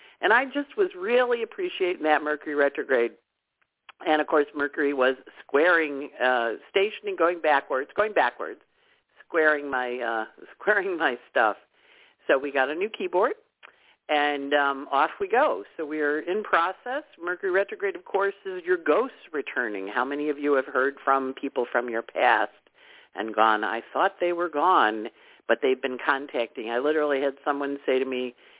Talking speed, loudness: 165 wpm, -25 LUFS